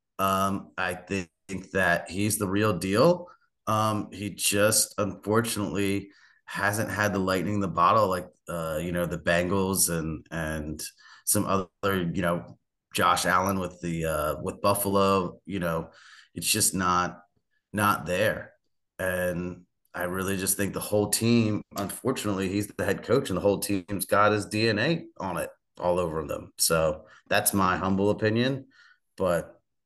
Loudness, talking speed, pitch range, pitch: -26 LUFS, 155 wpm, 90-105 Hz, 100 Hz